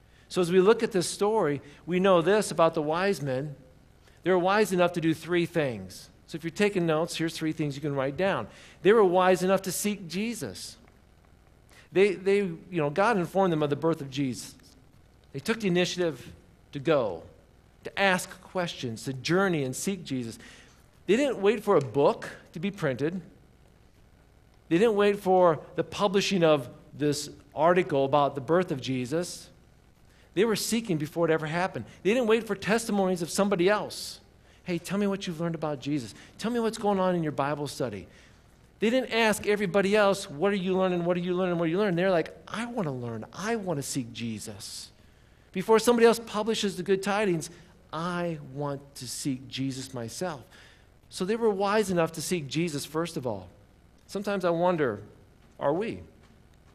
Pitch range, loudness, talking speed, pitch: 140-195 Hz, -27 LUFS, 190 wpm, 170 Hz